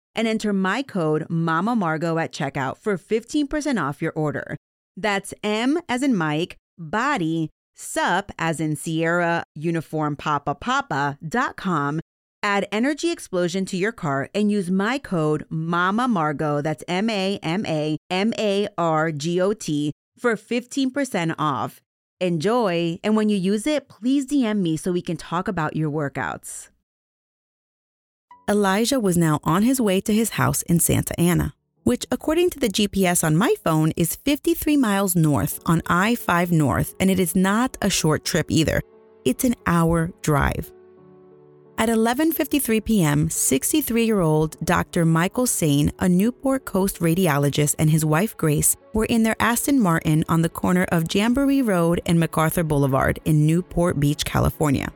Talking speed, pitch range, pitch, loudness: 155 wpm, 155-220 Hz, 180 Hz, -22 LUFS